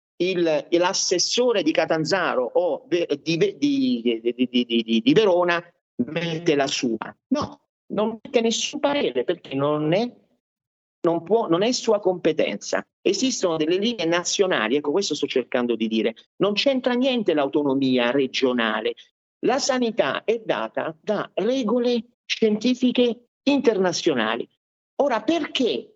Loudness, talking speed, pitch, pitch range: -22 LUFS, 125 wpm, 185 Hz, 155-245 Hz